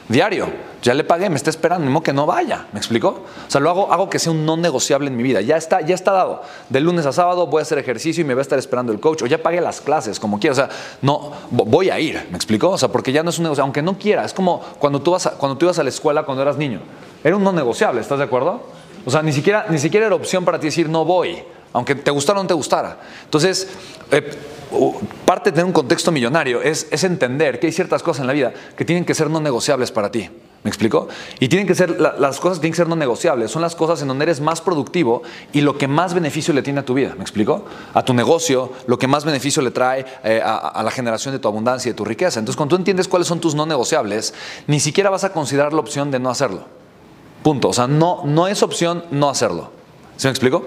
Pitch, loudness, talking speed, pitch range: 155 Hz, -18 LUFS, 270 wpm, 135-175 Hz